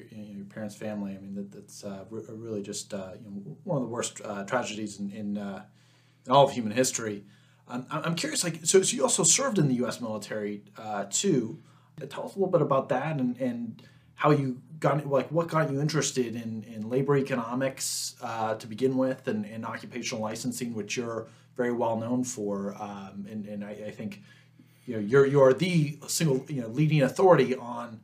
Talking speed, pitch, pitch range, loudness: 210 wpm, 125 Hz, 105-140 Hz, -28 LUFS